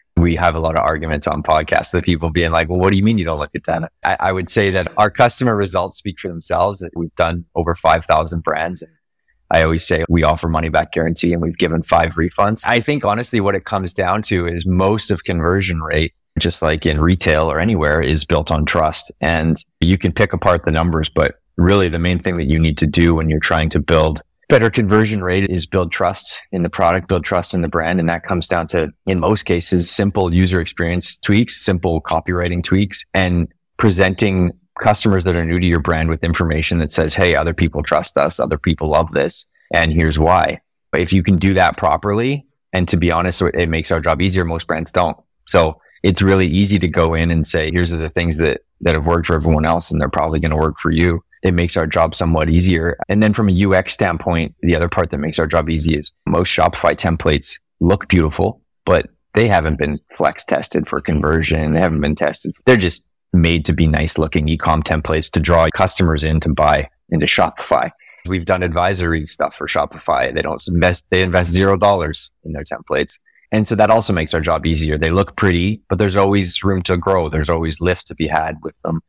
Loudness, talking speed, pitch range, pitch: -16 LUFS, 225 wpm, 80-95 Hz, 85 Hz